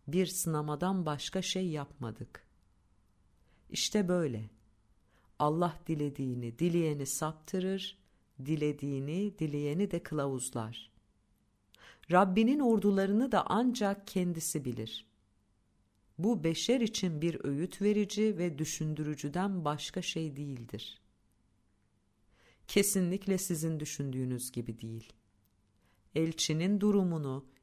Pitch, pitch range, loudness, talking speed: 150 Hz, 110-185 Hz, -33 LUFS, 85 wpm